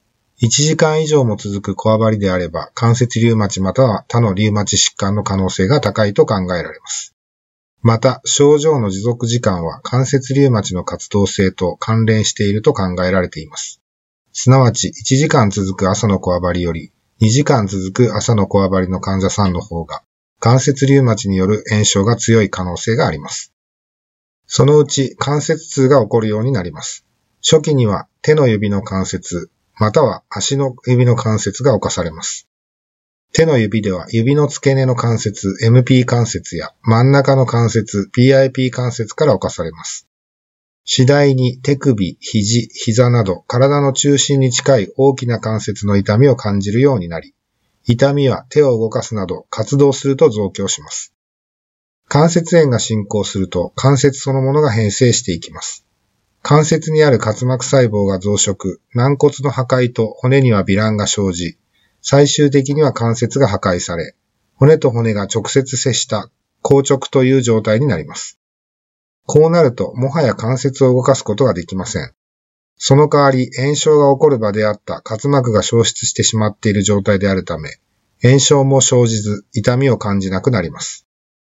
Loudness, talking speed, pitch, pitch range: -14 LUFS, 315 characters per minute, 115 Hz, 100-135 Hz